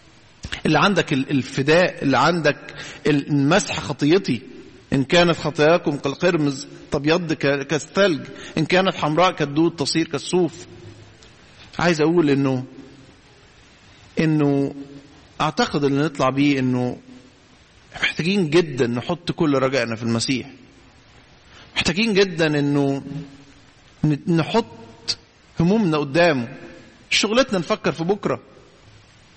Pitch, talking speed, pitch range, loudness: 145 Hz, 90 wpm, 135-170 Hz, -20 LUFS